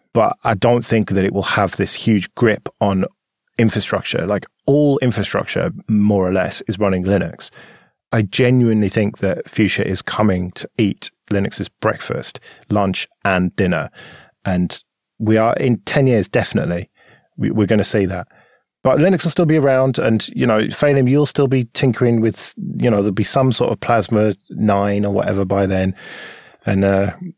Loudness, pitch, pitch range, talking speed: -17 LUFS, 110 Hz, 100-125 Hz, 175 wpm